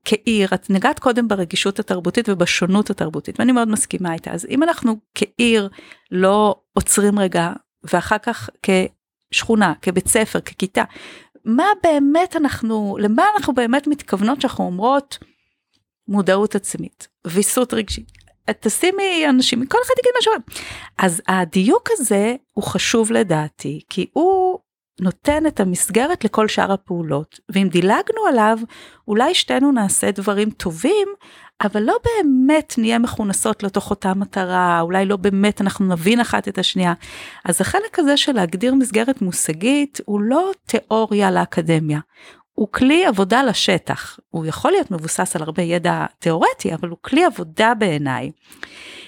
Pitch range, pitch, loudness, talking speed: 185-270 Hz, 215 Hz, -18 LUFS, 135 wpm